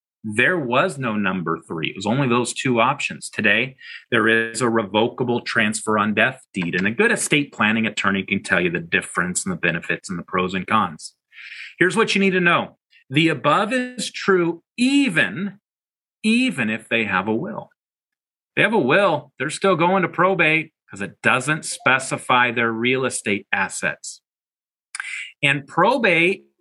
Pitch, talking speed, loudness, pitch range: 130 Hz, 170 wpm, -20 LUFS, 110-180 Hz